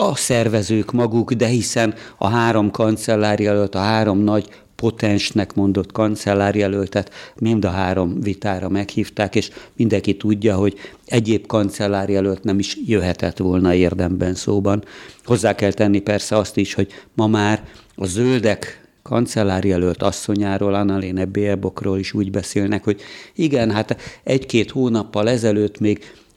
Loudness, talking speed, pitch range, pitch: -19 LUFS, 125 wpm, 100-110 Hz, 105 Hz